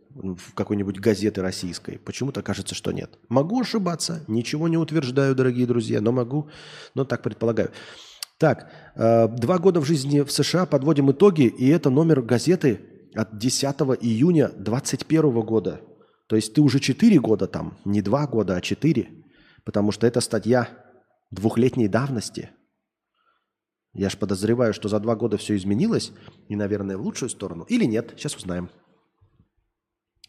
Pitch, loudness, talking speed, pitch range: 115 Hz, -23 LUFS, 145 wpm, 105-140 Hz